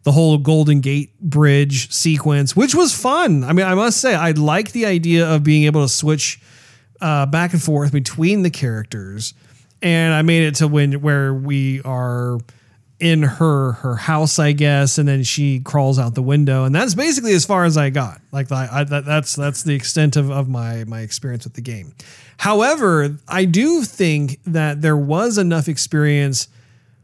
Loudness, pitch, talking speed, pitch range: -16 LUFS, 145 Hz, 190 wpm, 135-160 Hz